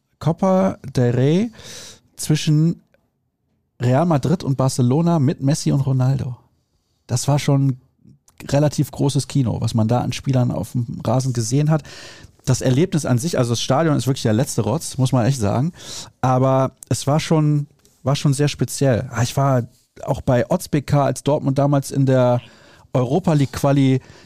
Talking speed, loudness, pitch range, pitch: 160 wpm, -19 LUFS, 125-145 Hz, 135 Hz